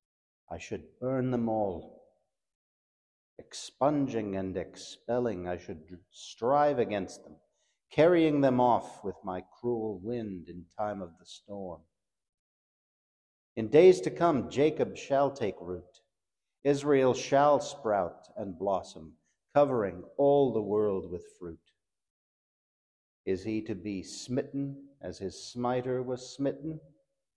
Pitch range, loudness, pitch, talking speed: 95-140 Hz, -29 LUFS, 110 Hz, 120 wpm